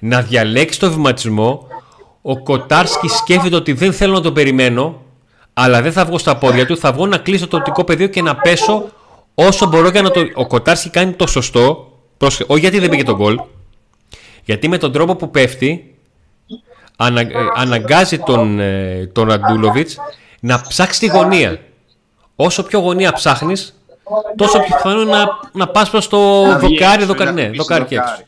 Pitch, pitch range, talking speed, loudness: 160 Hz, 125-190 Hz, 170 wpm, -13 LUFS